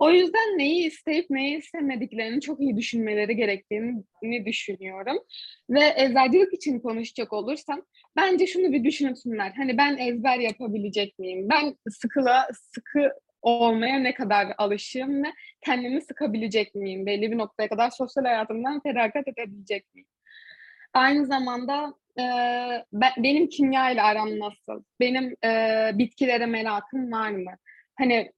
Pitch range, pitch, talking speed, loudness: 225-285 Hz, 250 Hz, 130 wpm, -25 LUFS